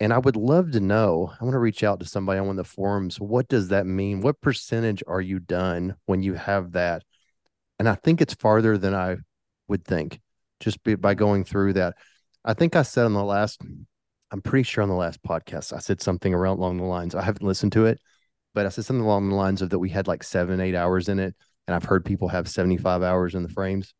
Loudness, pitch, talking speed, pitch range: -24 LUFS, 100 Hz, 245 wpm, 95-110 Hz